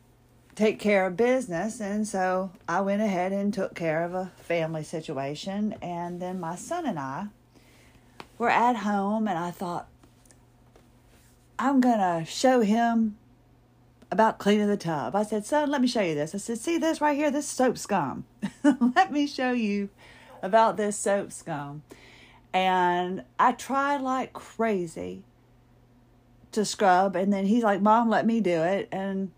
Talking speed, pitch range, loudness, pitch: 160 wpm, 160-225 Hz, -26 LUFS, 195 Hz